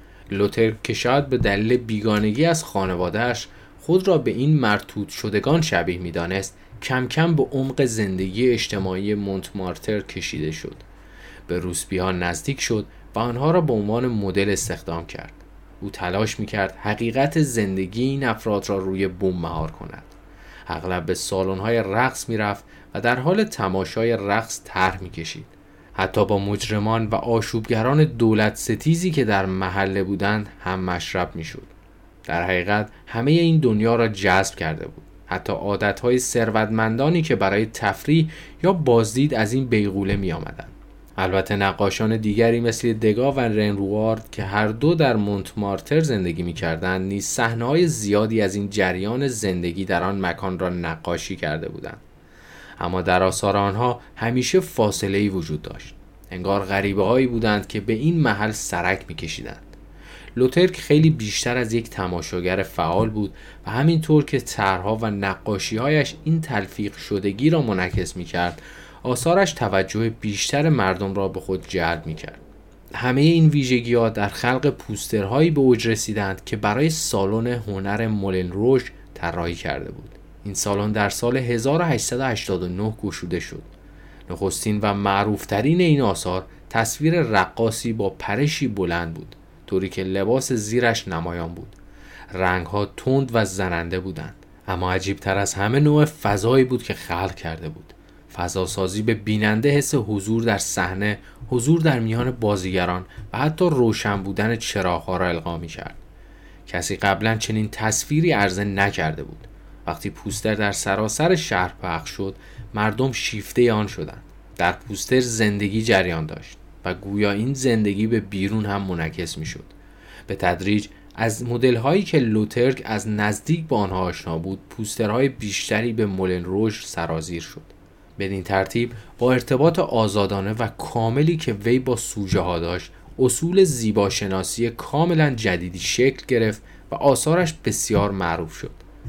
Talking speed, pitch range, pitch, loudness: 150 wpm, 95-120 Hz, 105 Hz, -22 LUFS